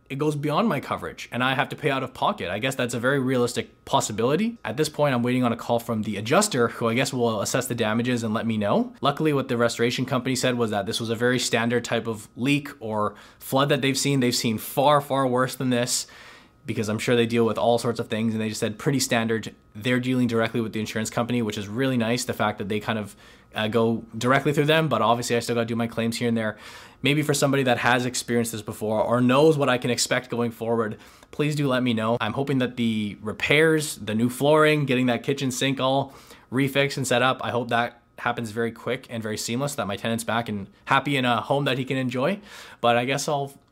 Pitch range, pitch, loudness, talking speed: 115-135 Hz, 120 Hz, -24 LUFS, 255 wpm